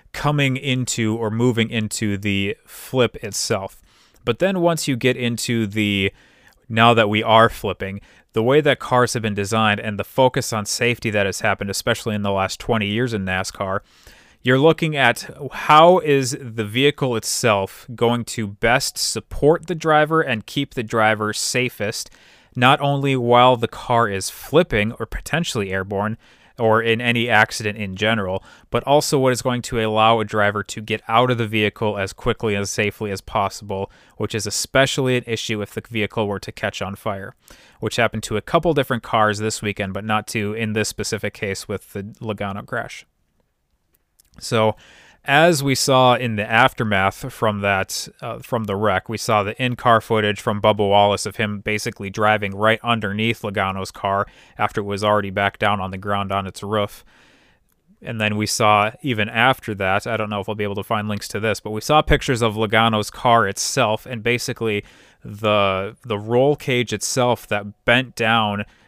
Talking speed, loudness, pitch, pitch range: 185 wpm, -20 LUFS, 110 Hz, 105-120 Hz